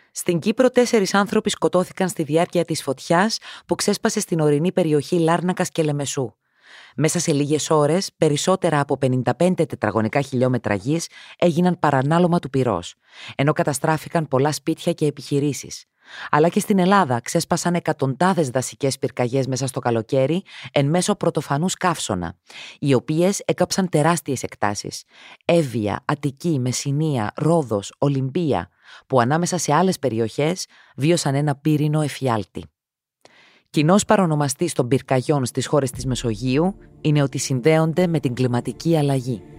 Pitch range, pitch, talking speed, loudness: 130-170 Hz, 150 Hz, 130 wpm, -21 LUFS